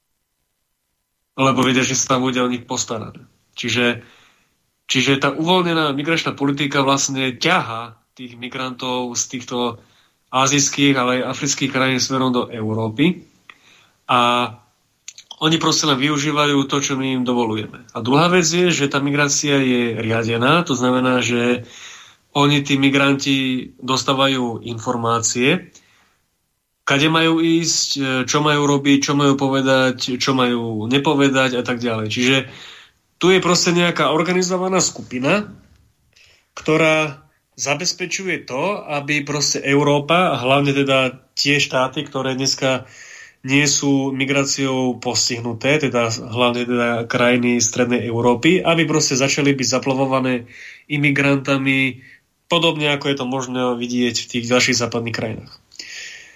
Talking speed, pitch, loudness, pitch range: 125 wpm, 135 Hz, -17 LUFS, 125-145 Hz